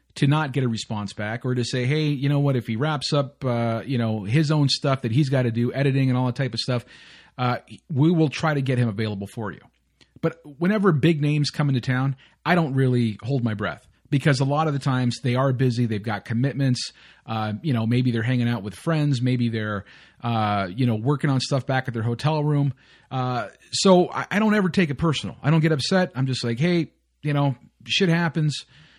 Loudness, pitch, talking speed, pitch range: -23 LUFS, 135 Hz, 235 wpm, 120-150 Hz